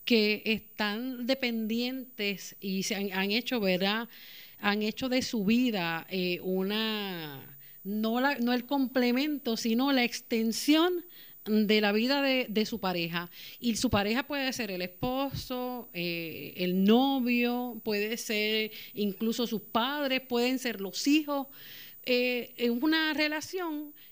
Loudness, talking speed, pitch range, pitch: -29 LUFS, 135 wpm, 205-255 Hz, 230 Hz